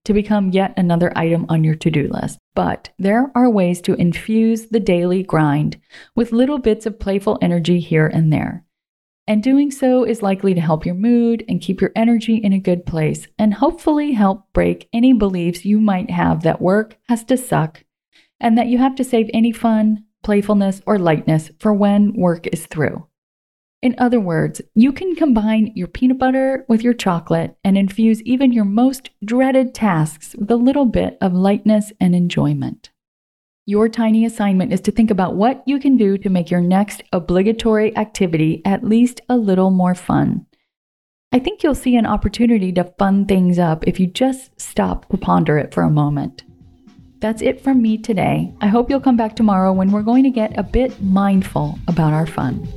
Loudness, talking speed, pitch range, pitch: -17 LUFS, 190 wpm, 180-235 Hz, 210 Hz